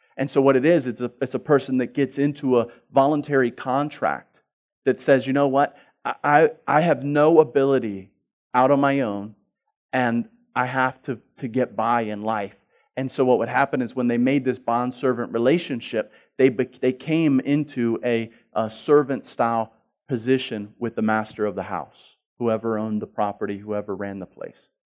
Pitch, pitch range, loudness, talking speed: 125 Hz, 110-140 Hz, -22 LUFS, 180 wpm